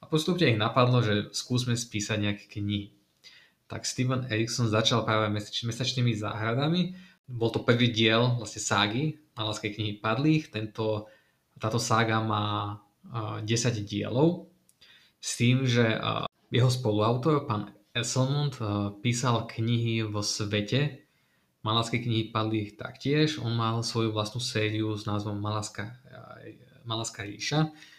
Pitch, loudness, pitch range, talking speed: 115 Hz, -28 LUFS, 105-125 Hz, 115 wpm